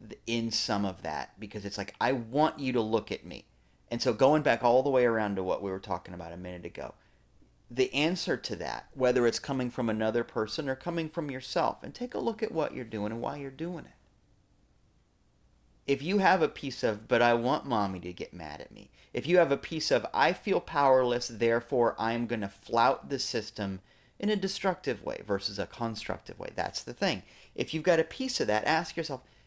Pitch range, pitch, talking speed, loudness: 105-150 Hz, 120 Hz, 220 wpm, -30 LUFS